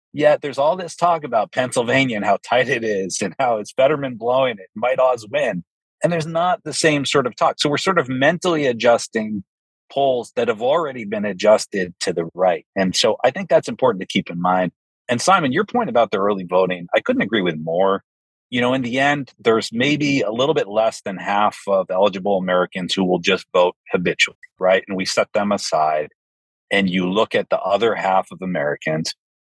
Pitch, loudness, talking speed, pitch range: 110 Hz, -19 LUFS, 210 wpm, 90-140 Hz